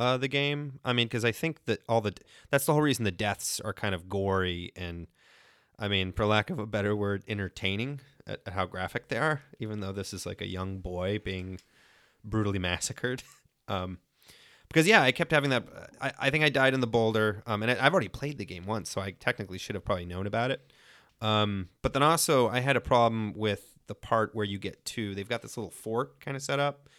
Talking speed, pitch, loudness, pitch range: 240 wpm, 110 Hz, -29 LUFS, 100-130 Hz